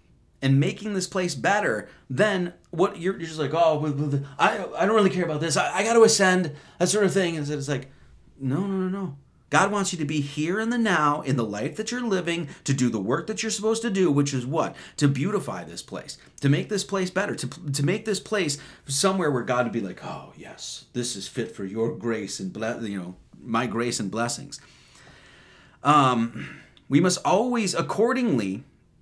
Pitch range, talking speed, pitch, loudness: 130-190 Hz, 215 wpm, 150 Hz, -25 LUFS